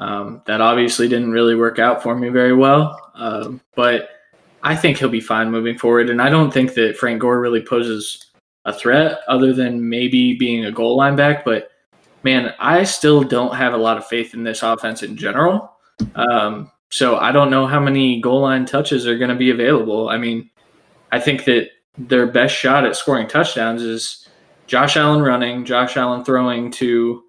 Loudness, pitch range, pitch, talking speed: -16 LUFS, 115-130 Hz, 120 Hz, 195 wpm